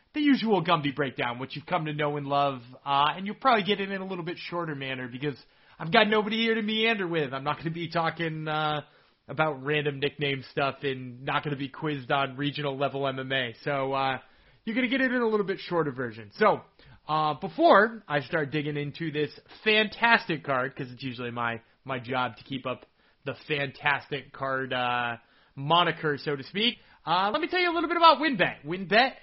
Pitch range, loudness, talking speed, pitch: 135-185 Hz, -27 LUFS, 205 wpm, 150 Hz